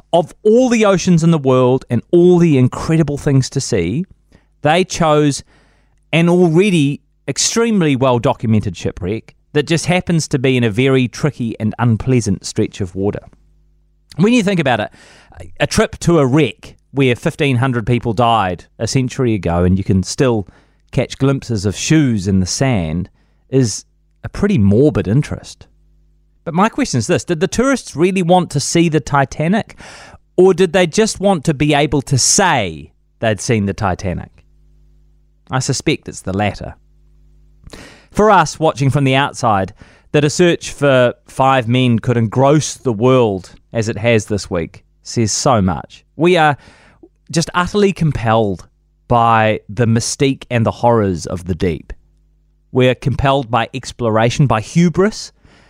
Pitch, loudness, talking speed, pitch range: 125 Hz, -15 LUFS, 160 wpm, 105-150 Hz